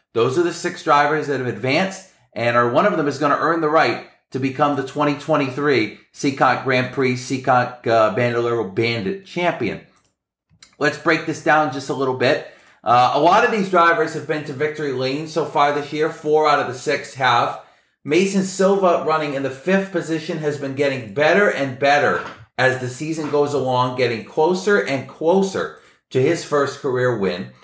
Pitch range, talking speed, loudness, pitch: 130-160 Hz, 190 wpm, -19 LUFS, 145 Hz